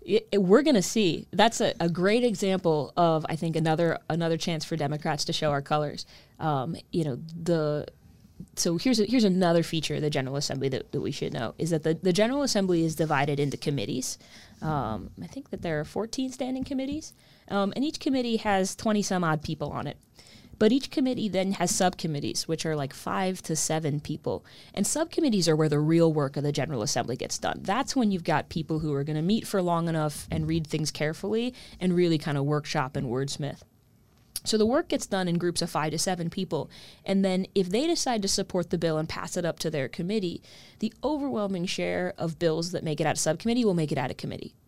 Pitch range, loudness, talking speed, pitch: 155-205 Hz, -27 LUFS, 225 wpm, 170 Hz